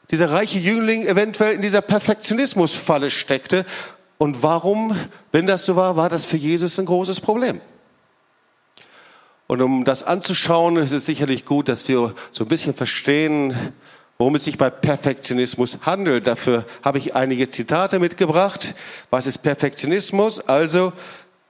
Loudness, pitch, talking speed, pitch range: -19 LUFS, 165 Hz, 140 wpm, 140-190 Hz